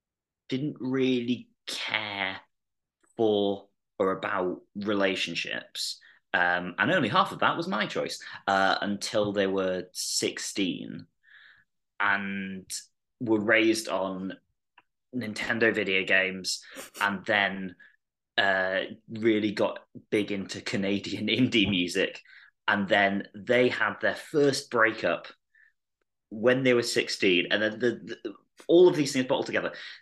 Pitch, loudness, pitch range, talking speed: 105 Hz, -27 LUFS, 95-115 Hz, 120 wpm